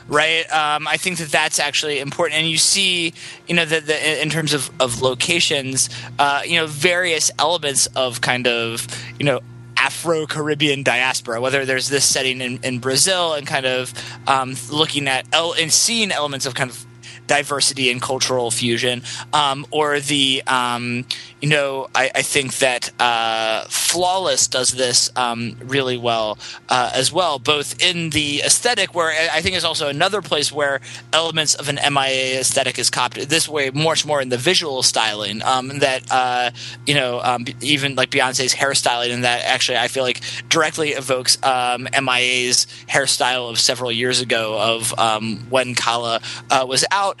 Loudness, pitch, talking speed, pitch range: -18 LUFS, 130 Hz, 175 wpm, 125-150 Hz